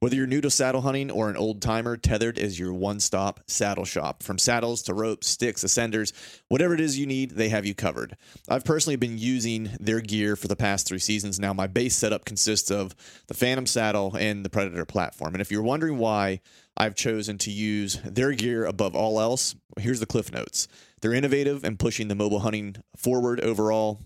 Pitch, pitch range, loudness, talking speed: 110 Hz, 105-120 Hz, -26 LUFS, 210 wpm